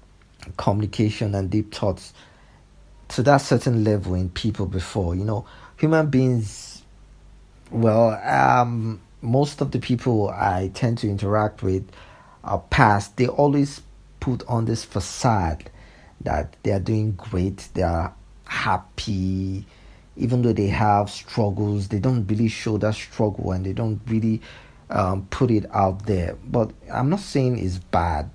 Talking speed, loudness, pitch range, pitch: 145 wpm, -23 LUFS, 95-115 Hz, 105 Hz